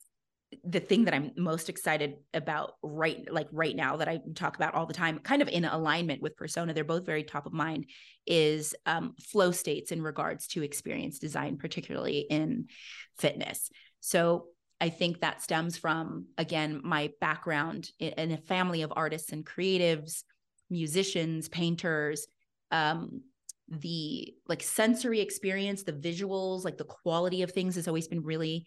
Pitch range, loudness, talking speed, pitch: 155-180 Hz, -32 LUFS, 160 wpm, 165 Hz